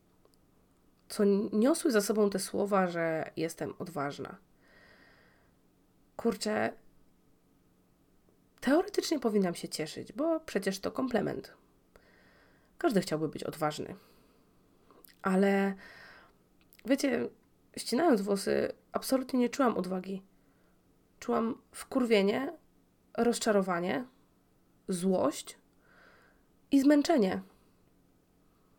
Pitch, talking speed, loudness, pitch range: 205 Hz, 75 wpm, -31 LUFS, 185-260 Hz